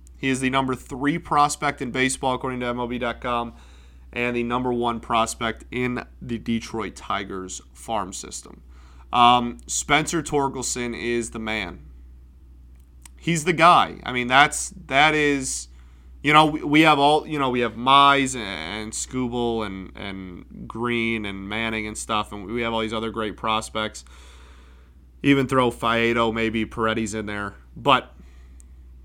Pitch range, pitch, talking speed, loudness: 85-125 Hz, 115 Hz, 150 wpm, -22 LUFS